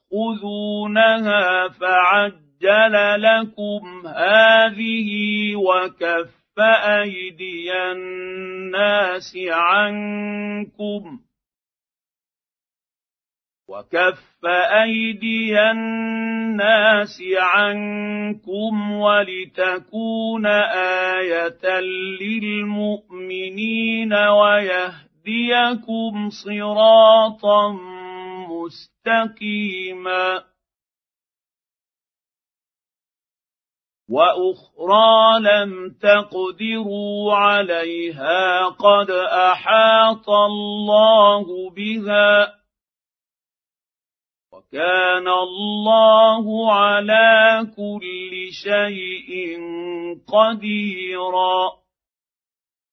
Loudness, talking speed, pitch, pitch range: -17 LUFS, 35 wpm, 205 Hz, 185-215 Hz